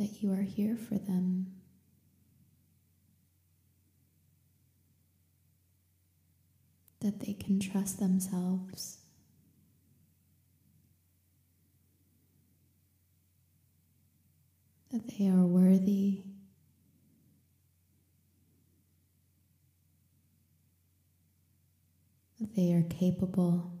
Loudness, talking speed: -31 LUFS, 50 wpm